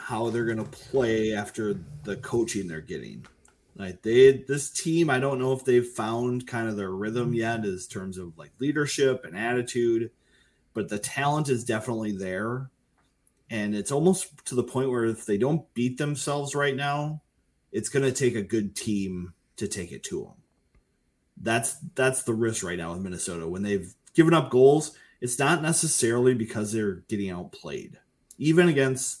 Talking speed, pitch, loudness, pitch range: 175 wpm, 120 Hz, -26 LUFS, 105-140 Hz